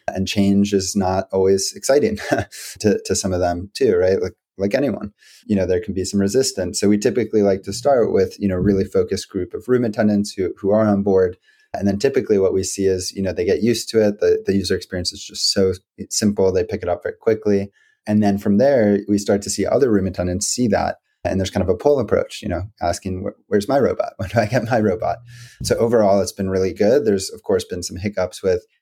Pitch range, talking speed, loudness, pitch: 95-105 Hz, 245 wpm, -19 LUFS, 100 Hz